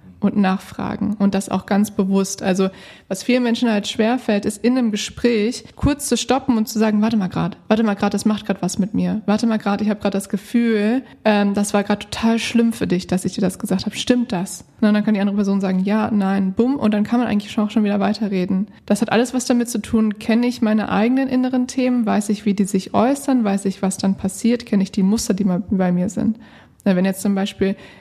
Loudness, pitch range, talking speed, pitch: -19 LUFS, 195-230 Hz, 250 wpm, 210 Hz